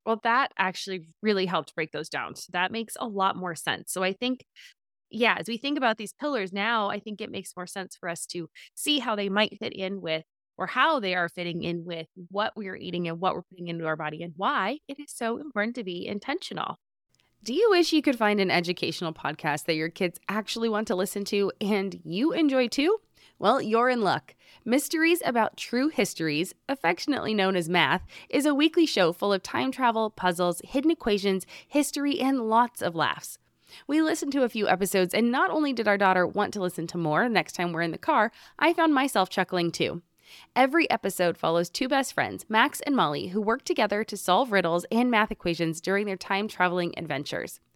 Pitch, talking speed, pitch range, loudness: 205 Hz, 210 wpm, 180-250 Hz, -27 LUFS